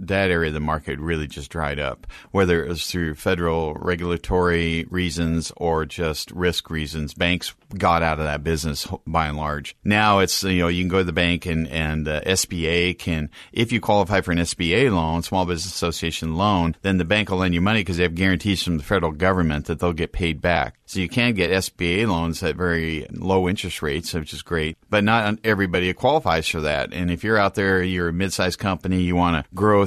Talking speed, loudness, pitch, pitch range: 220 wpm, -22 LUFS, 85 Hz, 80-95 Hz